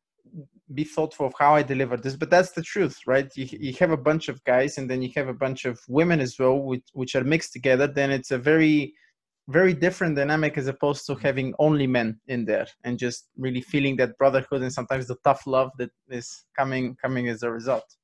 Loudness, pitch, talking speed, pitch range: -24 LUFS, 135 Hz, 225 wpm, 130-150 Hz